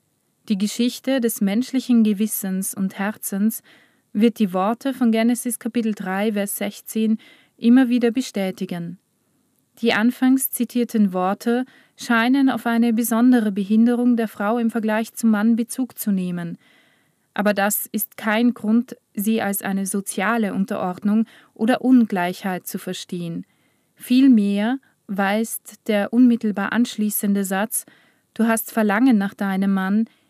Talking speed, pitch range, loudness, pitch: 125 wpm, 200-240 Hz, -20 LUFS, 220 Hz